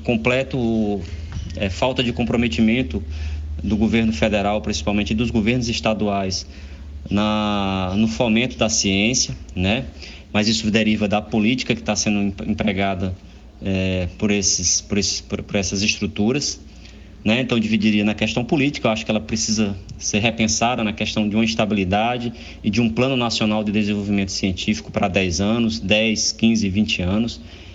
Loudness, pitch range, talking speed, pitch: -20 LUFS, 100-110 Hz, 150 wpm, 105 Hz